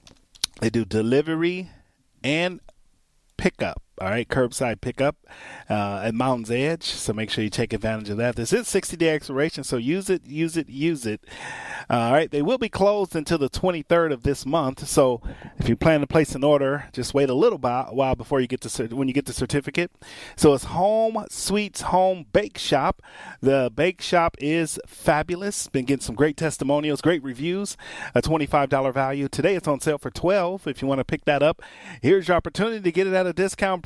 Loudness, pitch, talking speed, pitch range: -23 LUFS, 145 Hz, 200 wpm, 130-170 Hz